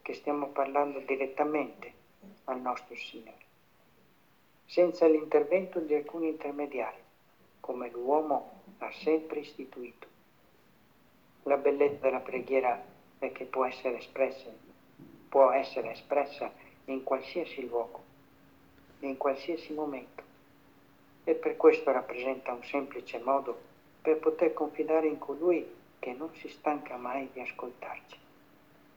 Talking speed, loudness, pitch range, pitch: 110 wpm, -31 LUFS, 130-155 Hz, 140 Hz